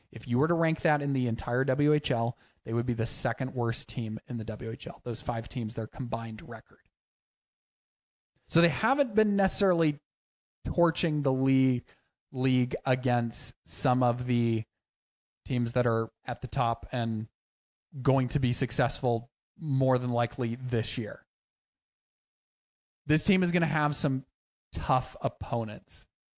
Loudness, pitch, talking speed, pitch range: -29 LUFS, 125 Hz, 145 wpm, 115-145 Hz